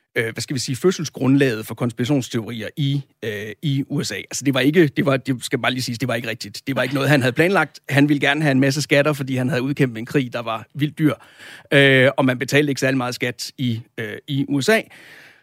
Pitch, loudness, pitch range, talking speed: 135 Hz, -20 LUFS, 125-145 Hz, 245 wpm